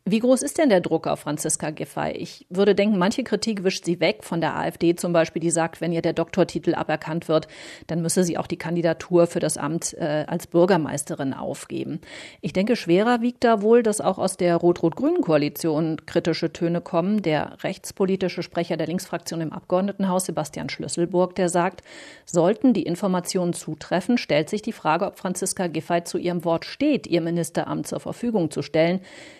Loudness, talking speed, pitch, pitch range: -23 LUFS, 180 wpm, 175 Hz, 165-195 Hz